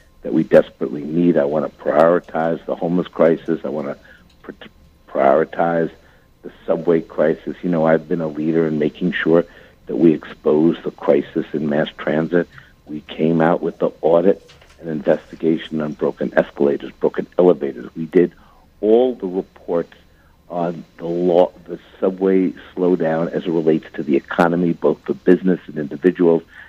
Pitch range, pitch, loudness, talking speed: 80-90 Hz, 85 Hz, -18 LUFS, 155 wpm